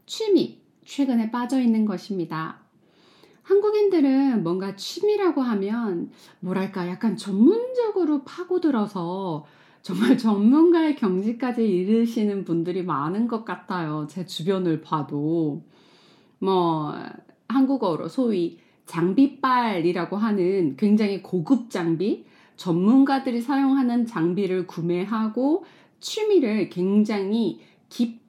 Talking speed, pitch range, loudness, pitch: 245 characters per minute, 180-270 Hz, -23 LUFS, 215 Hz